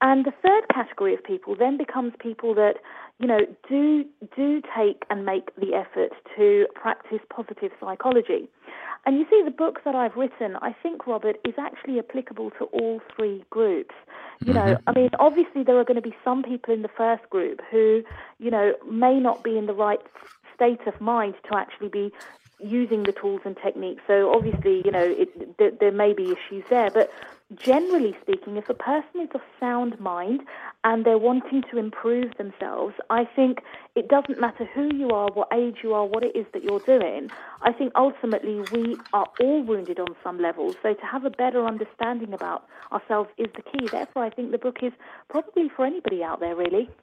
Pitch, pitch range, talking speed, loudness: 240 Hz, 210-280 Hz, 200 wpm, -24 LUFS